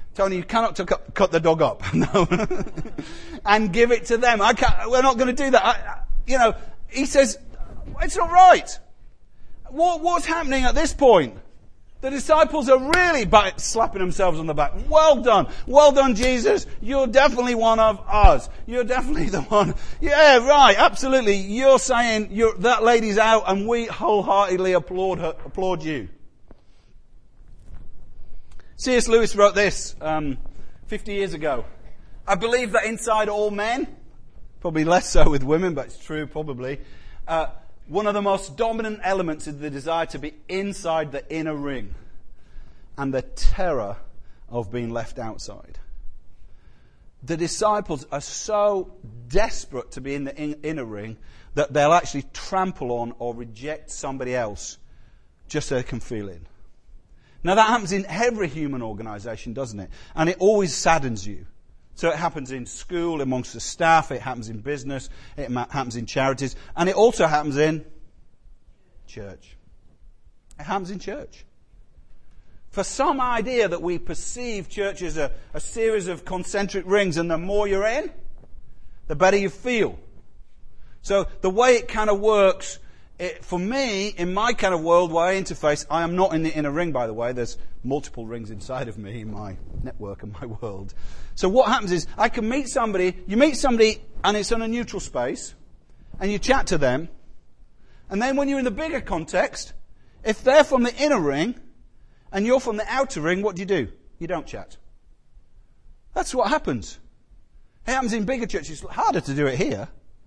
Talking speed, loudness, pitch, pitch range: 170 wpm, -21 LUFS, 185 Hz, 140-230 Hz